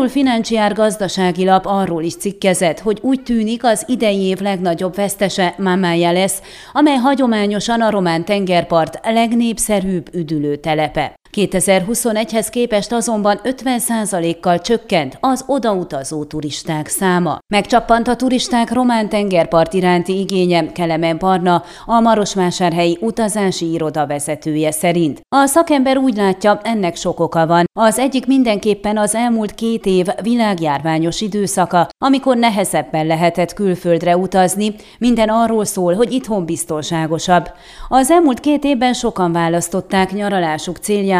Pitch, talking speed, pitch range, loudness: 195 Hz, 120 wpm, 170-230 Hz, -16 LUFS